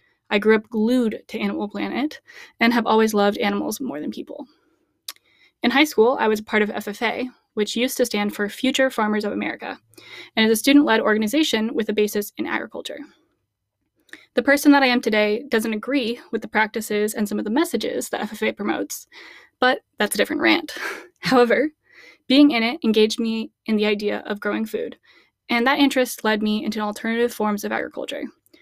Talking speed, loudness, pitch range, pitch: 185 wpm, -21 LUFS, 215-275 Hz, 230 Hz